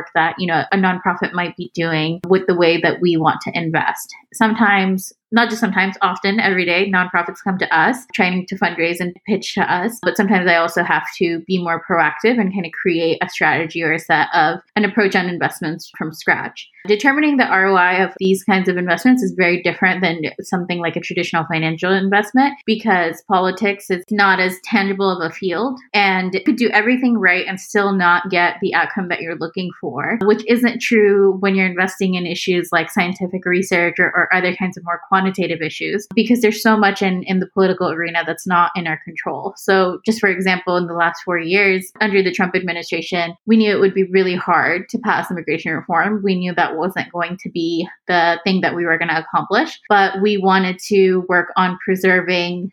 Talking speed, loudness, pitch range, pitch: 205 wpm, -17 LUFS, 175-200 Hz, 185 Hz